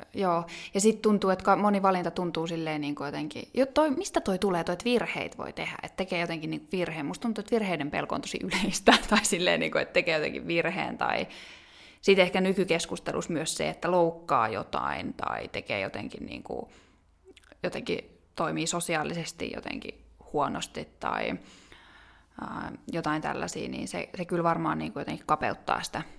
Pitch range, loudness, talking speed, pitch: 165-200 Hz, -29 LUFS, 170 wpm, 175 Hz